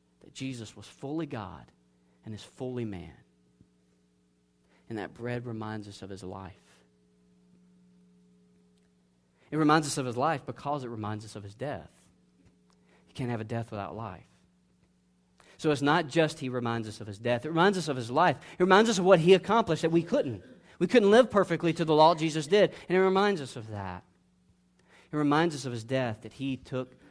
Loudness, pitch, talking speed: -28 LUFS, 110 Hz, 195 wpm